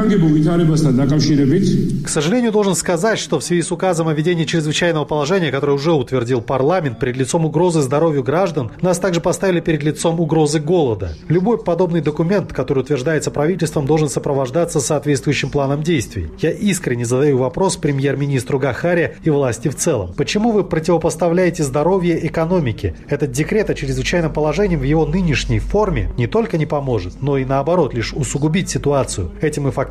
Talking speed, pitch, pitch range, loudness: 155 wpm, 155 Hz, 140-175 Hz, -17 LUFS